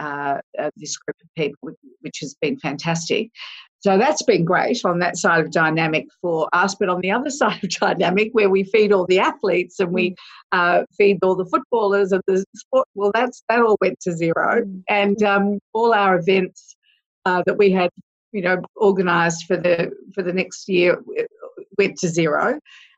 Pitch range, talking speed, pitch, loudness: 180-210 Hz, 190 wpm, 190 Hz, -19 LUFS